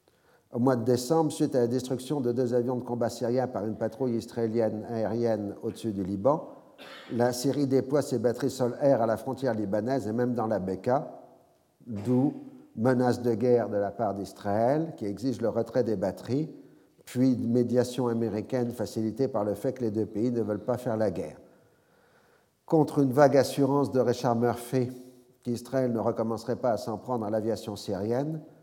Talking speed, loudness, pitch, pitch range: 180 wpm, -28 LUFS, 120 Hz, 110-130 Hz